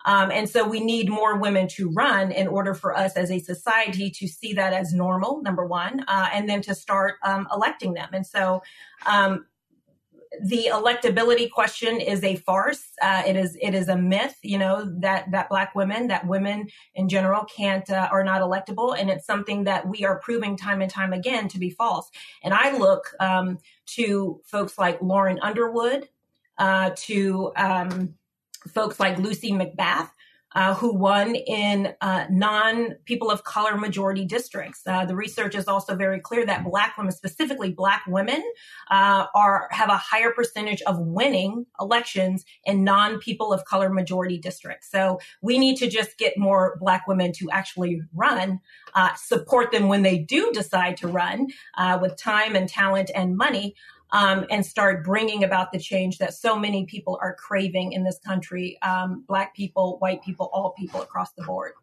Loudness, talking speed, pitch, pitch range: -23 LUFS, 180 wpm, 195 Hz, 185-215 Hz